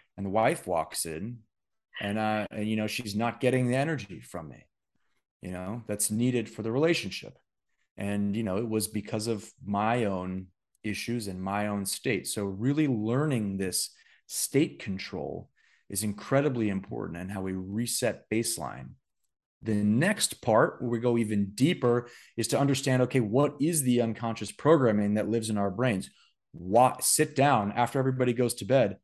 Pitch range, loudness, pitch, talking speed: 100-125 Hz, -28 LUFS, 110 Hz, 170 wpm